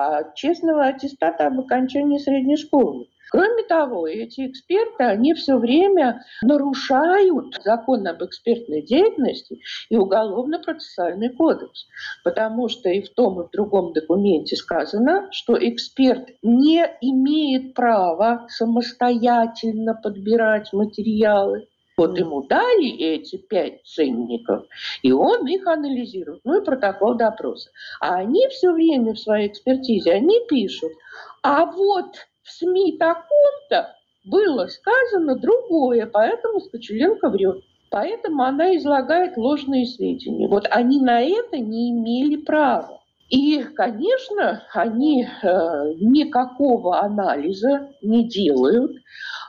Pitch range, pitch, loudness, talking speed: 220-315 Hz, 255 Hz, -20 LUFS, 115 wpm